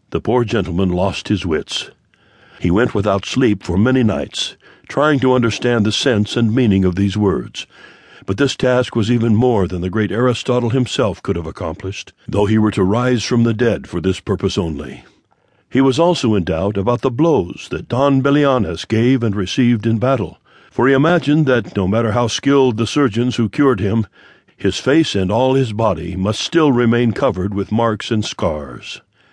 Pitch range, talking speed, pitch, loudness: 100-130 Hz, 190 wpm, 115 Hz, -16 LUFS